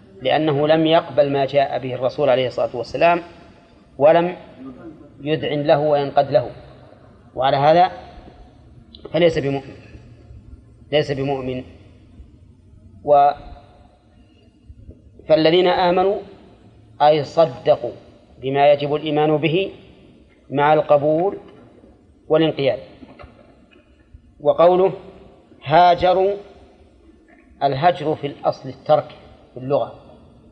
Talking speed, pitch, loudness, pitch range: 80 wpm, 145 Hz, -18 LUFS, 115-160 Hz